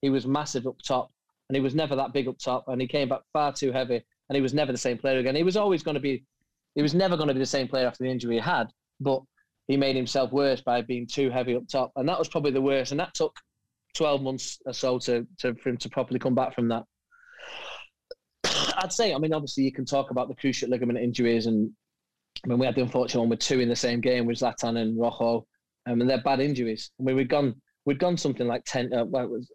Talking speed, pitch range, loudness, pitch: 265 wpm, 125-140 Hz, -27 LUFS, 130 Hz